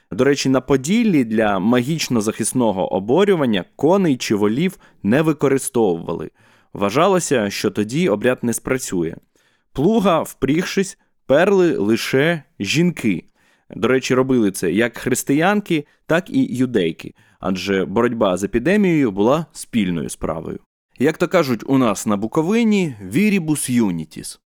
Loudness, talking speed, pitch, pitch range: -18 LUFS, 120 wpm, 135 Hz, 115-175 Hz